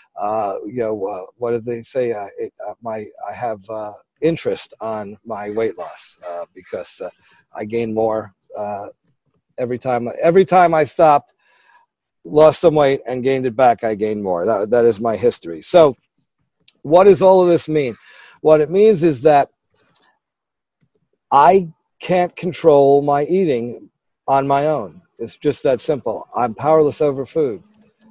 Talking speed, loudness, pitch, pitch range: 160 wpm, -17 LUFS, 140 Hz, 115-170 Hz